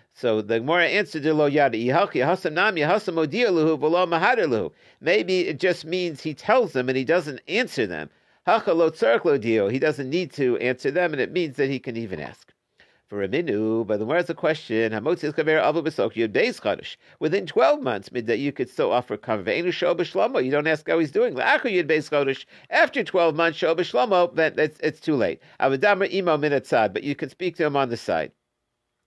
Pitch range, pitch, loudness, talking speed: 135-175 Hz, 155 Hz, -23 LUFS, 200 wpm